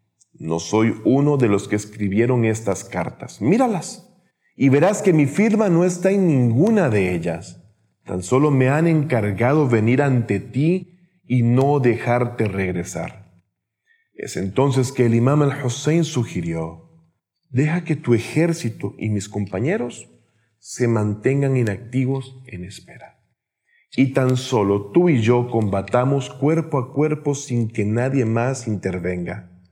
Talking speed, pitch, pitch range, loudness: 135 wpm, 125 Hz, 105-145 Hz, -20 LUFS